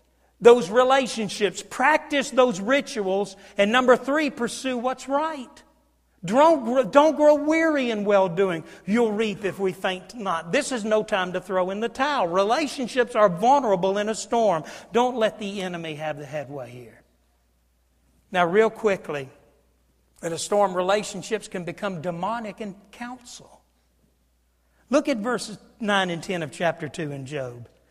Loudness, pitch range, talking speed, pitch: -23 LUFS, 170-245 Hz, 150 wpm, 205 Hz